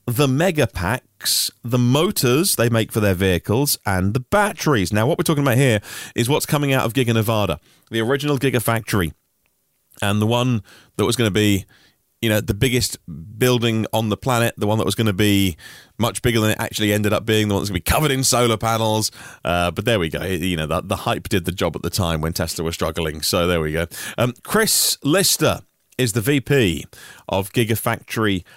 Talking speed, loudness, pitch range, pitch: 215 wpm, -19 LUFS, 95-125 Hz, 110 Hz